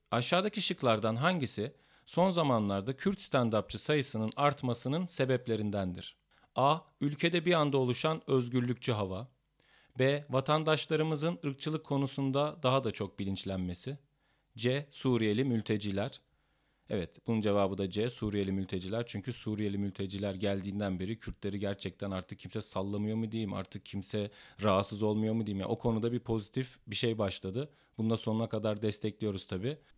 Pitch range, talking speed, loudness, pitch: 100-140 Hz, 130 wpm, -33 LUFS, 115 Hz